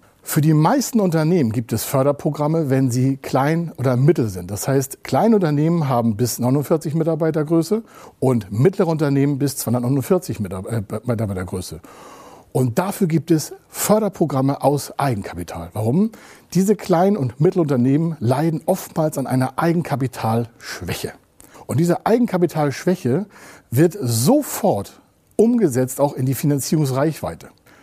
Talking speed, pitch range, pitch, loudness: 115 wpm, 125-170 Hz, 145 Hz, -19 LUFS